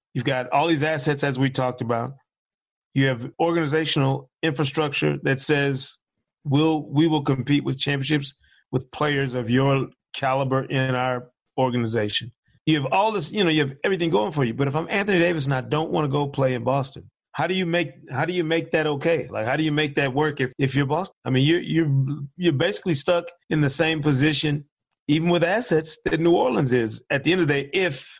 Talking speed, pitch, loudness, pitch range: 215 wpm, 145 Hz, -23 LUFS, 135-160 Hz